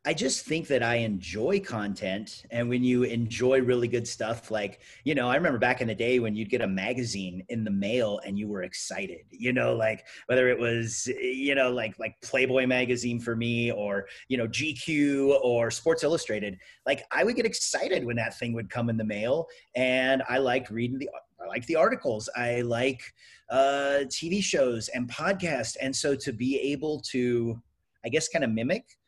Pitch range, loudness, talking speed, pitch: 110-130 Hz, -28 LUFS, 200 wpm, 120 Hz